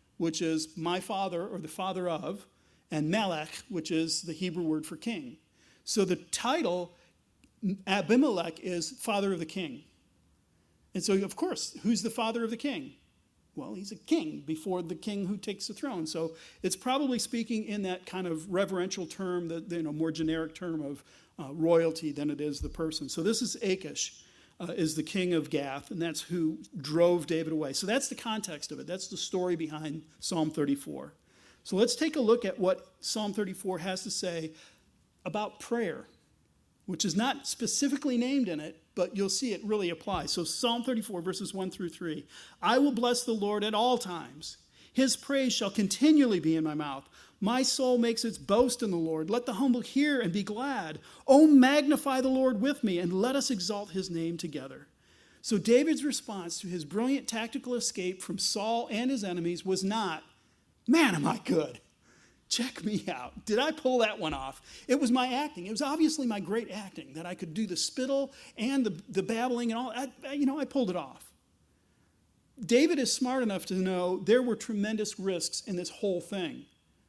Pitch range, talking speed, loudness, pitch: 170-240 Hz, 195 wpm, -30 LUFS, 195 Hz